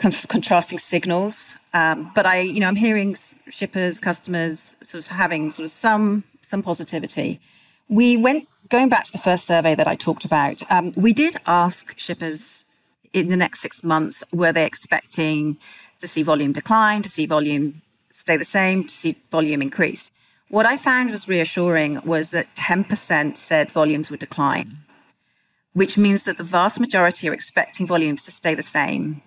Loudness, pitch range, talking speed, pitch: -20 LUFS, 160-205 Hz, 170 wpm, 175 Hz